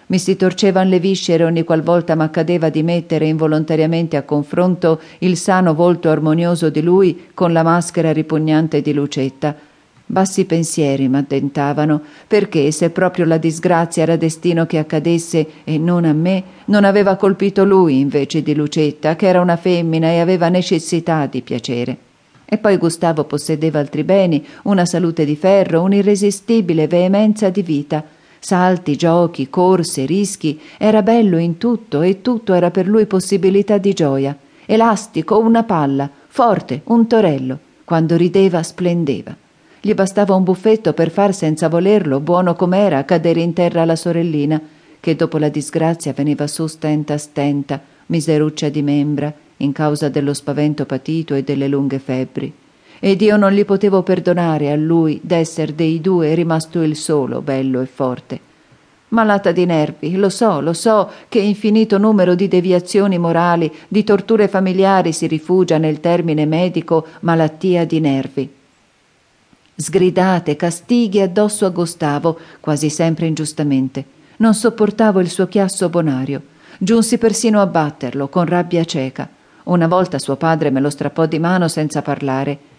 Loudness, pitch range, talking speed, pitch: -15 LUFS, 150-190 Hz, 150 wpm, 165 Hz